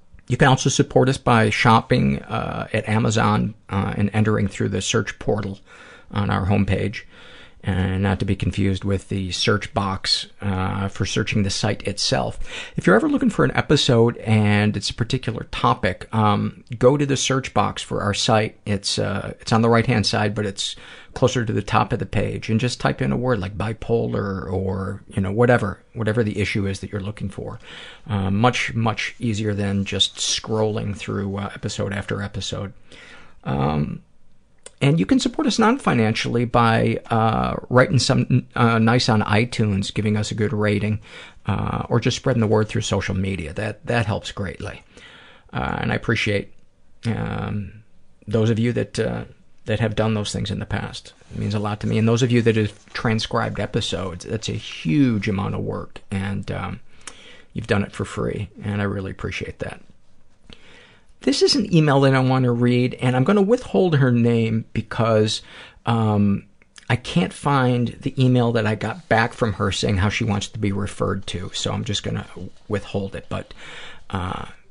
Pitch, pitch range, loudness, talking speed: 110 Hz, 100-120 Hz, -21 LUFS, 190 wpm